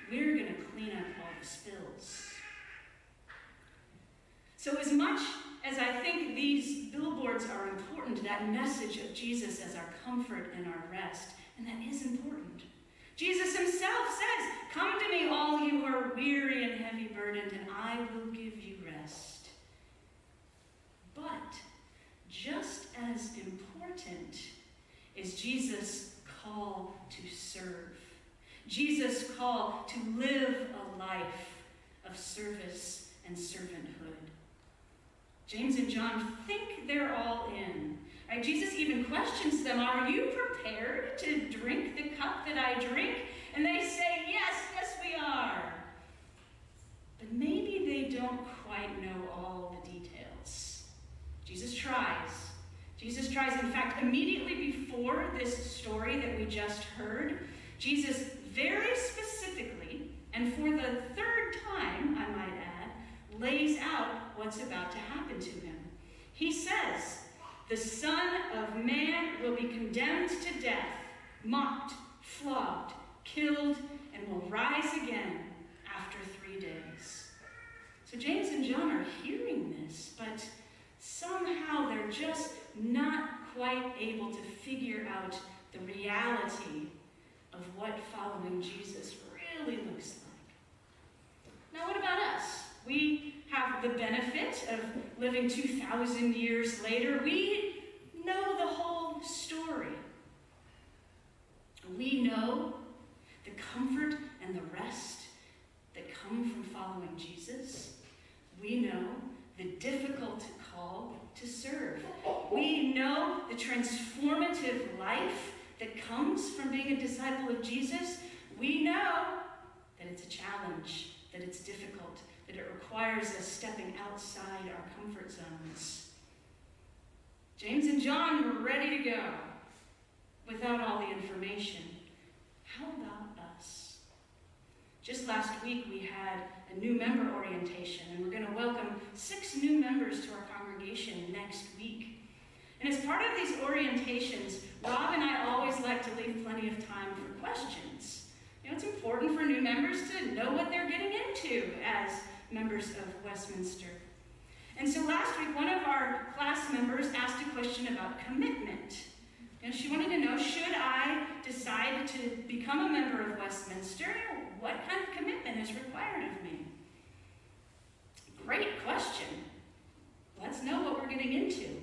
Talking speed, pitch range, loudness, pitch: 130 wpm, 200-295 Hz, -36 LUFS, 245 Hz